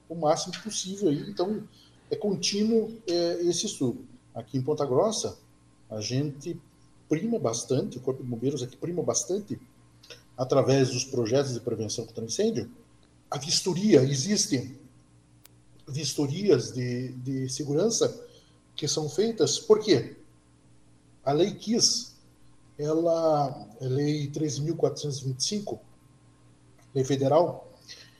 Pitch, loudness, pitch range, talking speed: 135 Hz, -27 LUFS, 110-165 Hz, 110 wpm